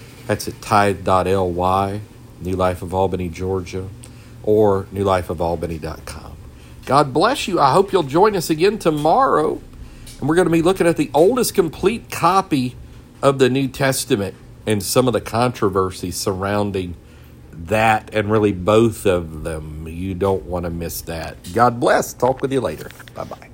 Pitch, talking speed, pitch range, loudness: 100 Hz, 155 wpm, 90-120 Hz, -18 LUFS